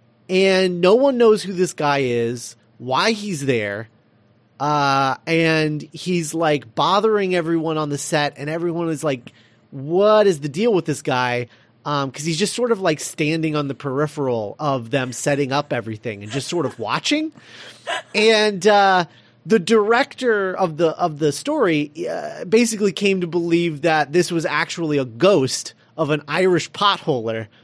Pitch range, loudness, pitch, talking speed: 135-185 Hz, -19 LUFS, 155 Hz, 165 wpm